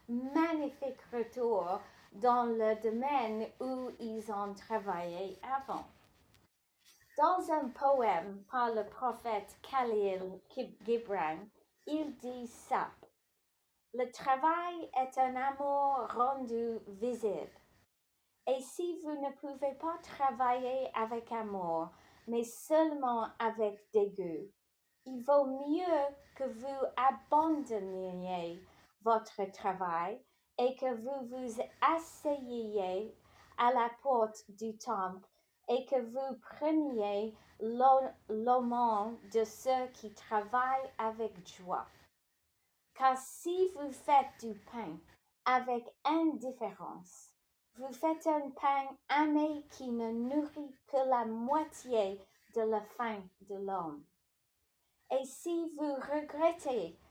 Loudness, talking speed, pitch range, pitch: -35 LUFS, 105 wpm, 215-275 Hz, 245 Hz